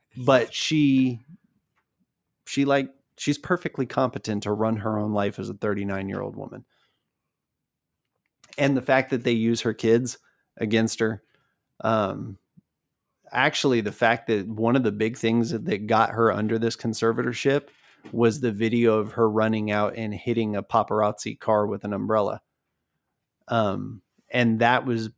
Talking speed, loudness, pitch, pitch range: 145 wpm, -24 LUFS, 115 Hz, 110-130 Hz